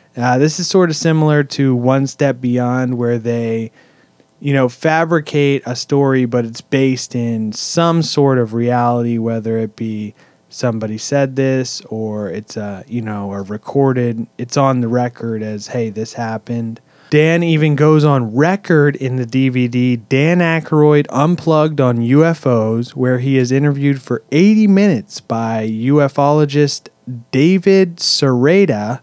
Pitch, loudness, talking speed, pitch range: 130 Hz, -15 LUFS, 145 wpm, 115-150 Hz